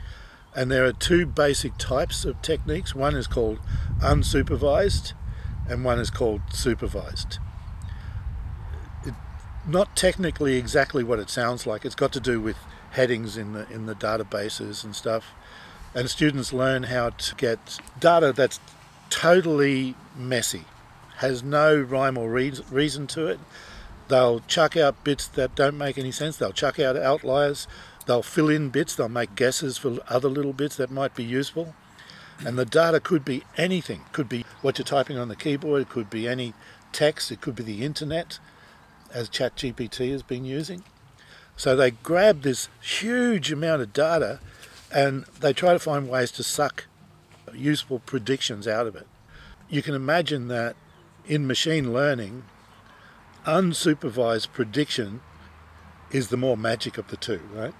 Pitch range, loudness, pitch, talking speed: 110-145 Hz, -25 LUFS, 130 Hz, 155 wpm